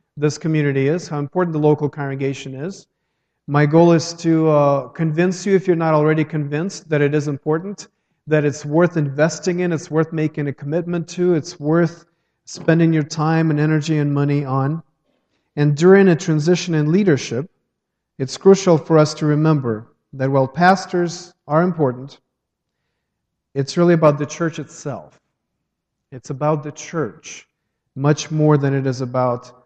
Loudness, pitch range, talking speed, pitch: -18 LUFS, 145-170 Hz, 160 wpm, 155 Hz